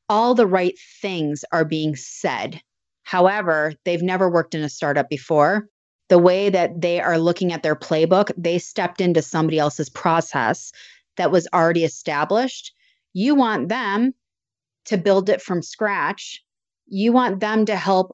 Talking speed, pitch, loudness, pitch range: 155 wpm, 180 Hz, -20 LUFS, 160-210 Hz